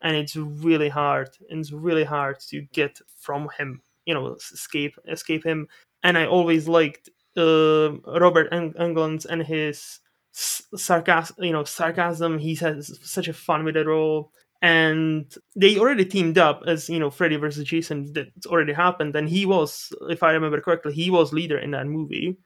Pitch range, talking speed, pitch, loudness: 150-170 Hz, 170 wpm, 160 Hz, -22 LUFS